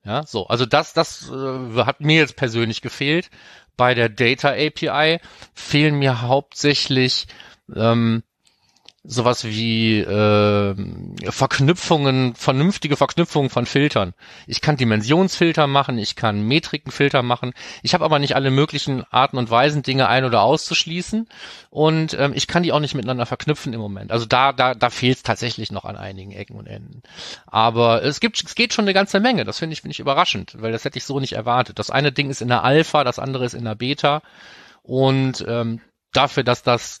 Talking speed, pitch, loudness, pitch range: 180 wpm, 130 Hz, -19 LUFS, 115-150 Hz